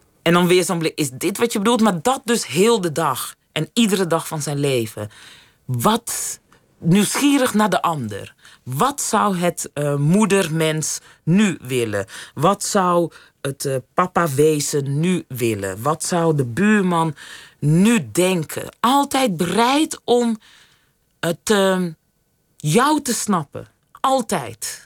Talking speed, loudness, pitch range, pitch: 140 wpm, -19 LUFS, 150-215 Hz, 175 Hz